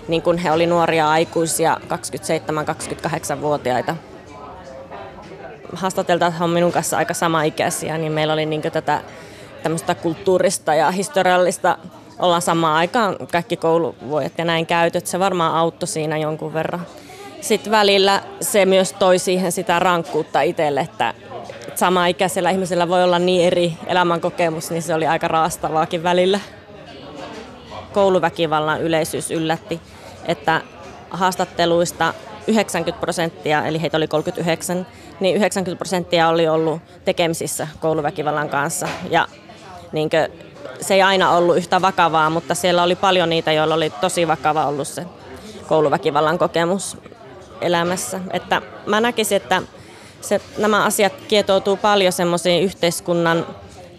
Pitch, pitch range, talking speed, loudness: 170 Hz, 160-185 Hz, 125 wpm, -19 LUFS